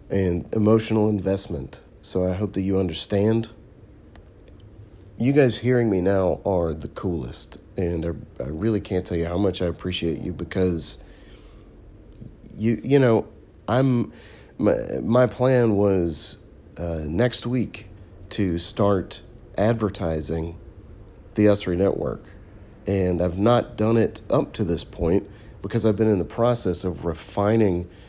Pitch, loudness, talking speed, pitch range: 100 Hz, -23 LUFS, 140 wpm, 90-110 Hz